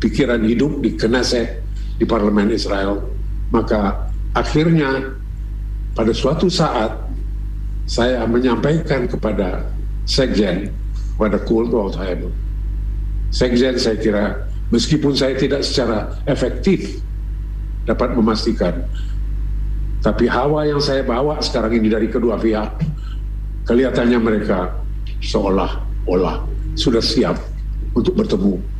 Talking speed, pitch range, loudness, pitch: 95 wpm, 100-125 Hz, -19 LUFS, 110 Hz